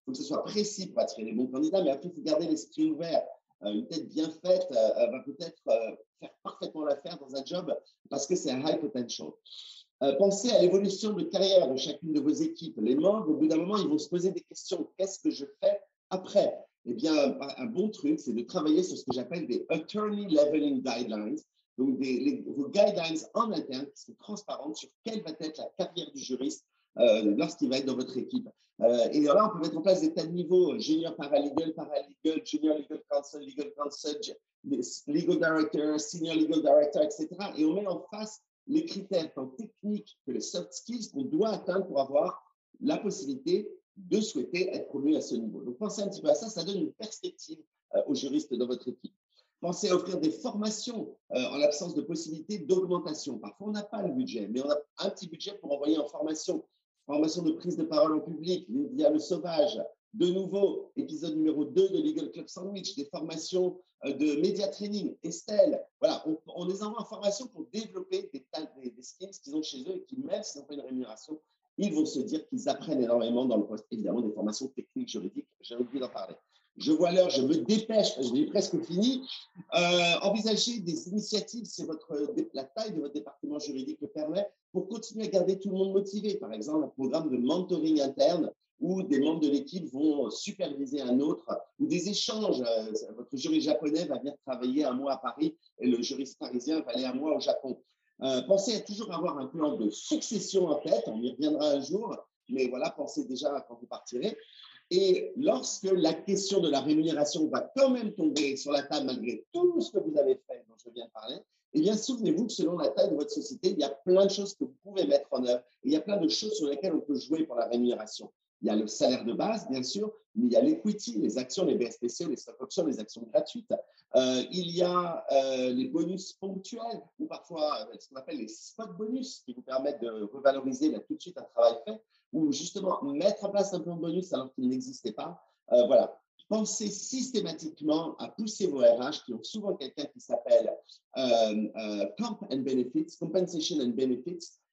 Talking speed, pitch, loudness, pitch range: 215 wpm, 185 Hz, -31 LUFS, 150-240 Hz